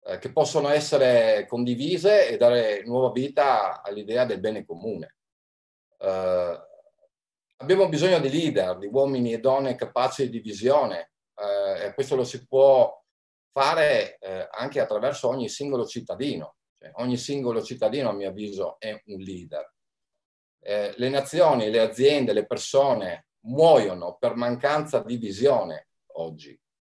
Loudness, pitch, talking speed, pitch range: -24 LUFS, 125 Hz, 130 wpm, 105-150 Hz